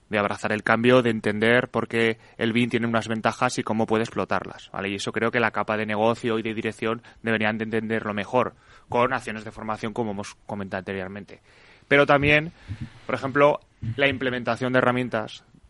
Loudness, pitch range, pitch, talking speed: -24 LUFS, 110-120 Hz, 115 Hz, 185 wpm